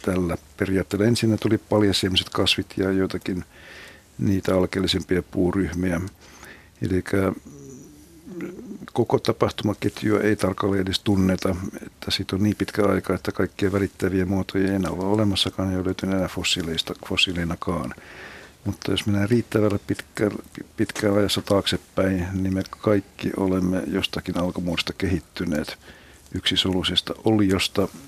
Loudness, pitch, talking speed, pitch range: -23 LUFS, 95 Hz, 115 wpm, 90-100 Hz